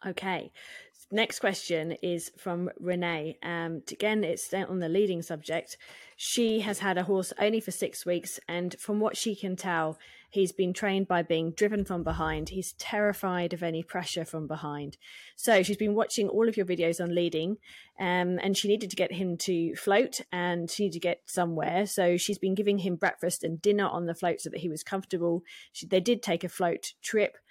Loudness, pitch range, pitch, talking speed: -30 LUFS, 170-200 Hz, 180 Hz, 200 wpm